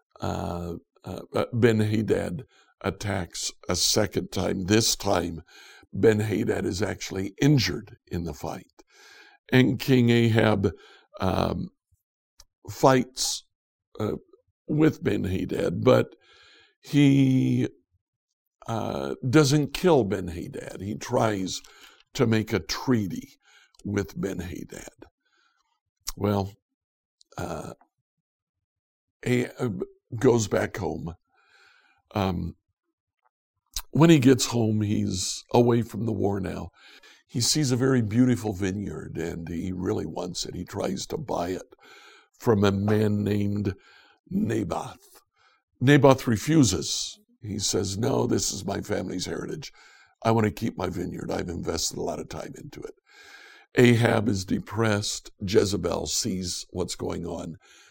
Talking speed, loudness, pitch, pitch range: 110 wpm, -25 LUFS, 105 Hz, 95-125 Hz